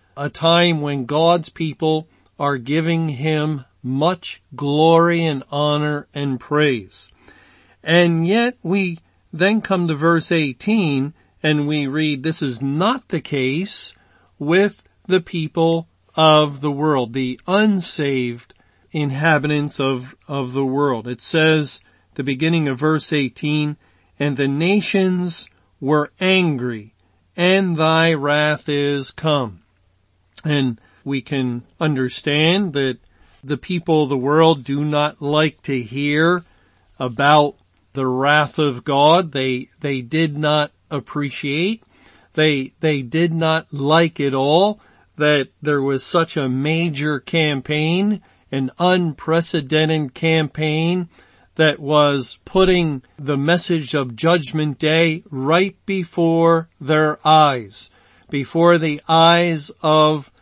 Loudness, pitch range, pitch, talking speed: -18 LUFS, 140-165 Hz, 150 Hz, 115 wpm